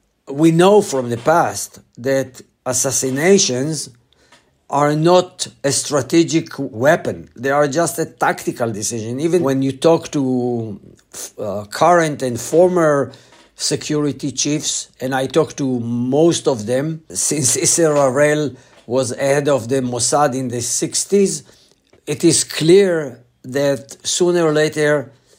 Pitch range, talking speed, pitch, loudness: 130-160 Hz, 125 wpm, 140 Hz, -17 LUFS